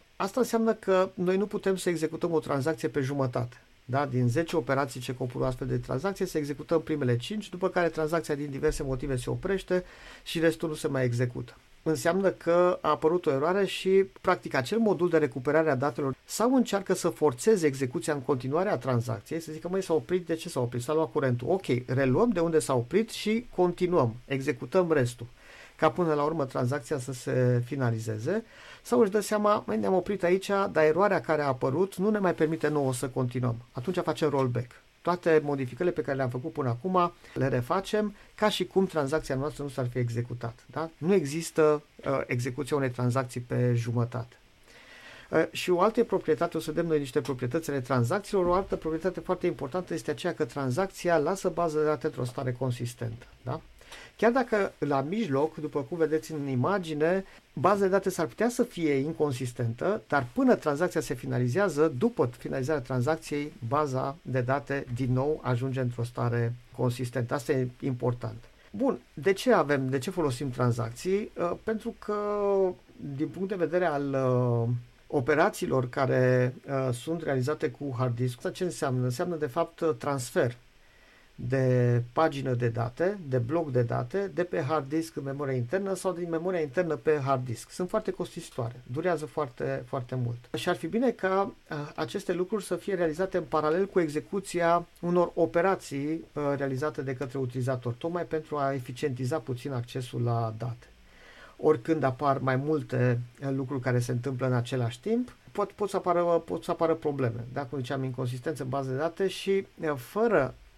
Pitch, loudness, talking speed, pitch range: 150 Hz, -29 LUFS, 175 wpm, 130-180 Hz